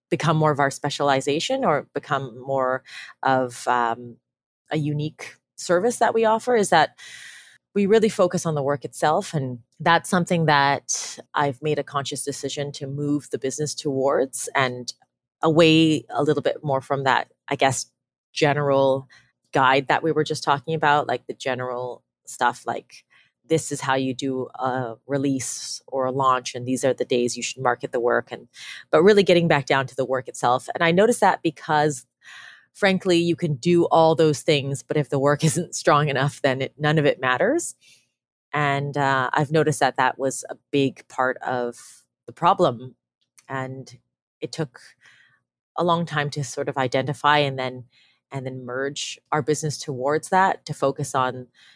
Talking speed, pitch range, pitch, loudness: 175 wpm, 130-155 Hz, 140 Hz, -22 LUFS